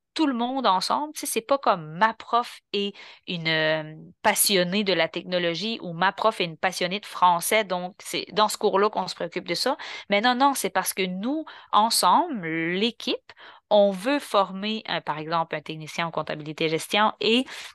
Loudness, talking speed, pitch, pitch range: -24 LUFS, 185 wpm, 200 Hz, 175-225 Hz